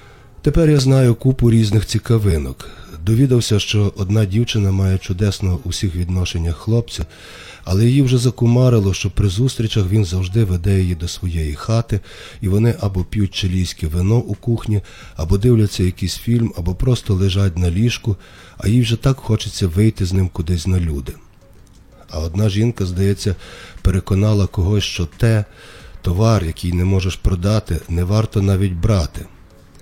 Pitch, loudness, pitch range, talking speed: 100 Hz, -18 LUFS, 90-115 Hz, 150 wpm